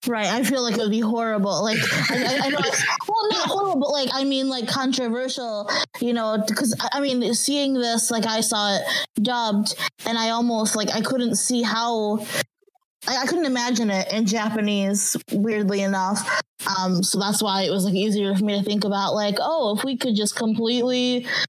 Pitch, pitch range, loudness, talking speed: 225 Hz, 210-250 Hz, -22 LUFS, 200 wpm